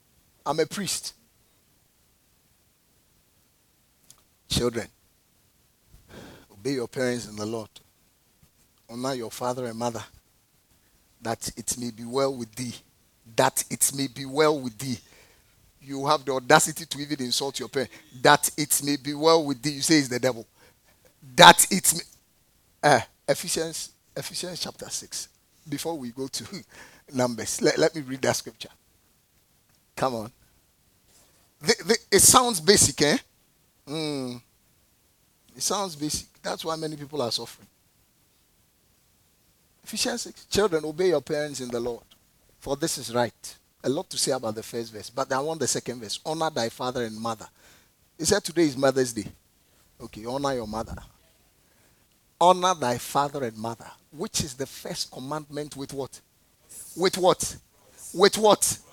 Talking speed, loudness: 150 wpm, -25 LUFS